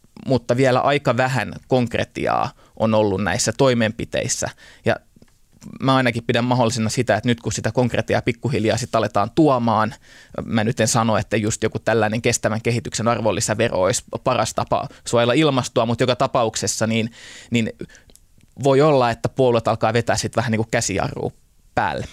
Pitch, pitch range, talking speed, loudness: 115 Hz, 110-125 Hz, 155 wpm, -20 LUFS